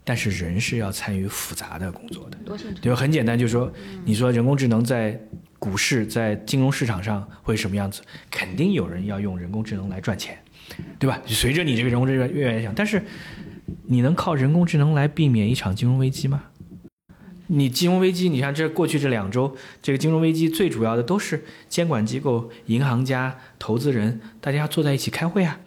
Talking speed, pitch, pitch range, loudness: 310 characters per minute, 130 Hz, 110-155 Hz, -23 LUFS